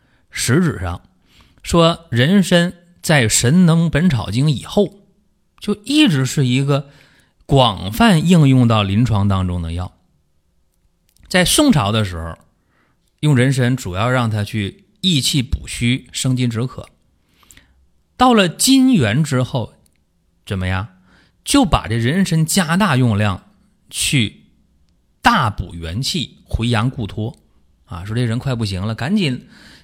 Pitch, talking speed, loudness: 125 Hz, 180 characters per minute, -16 LUFS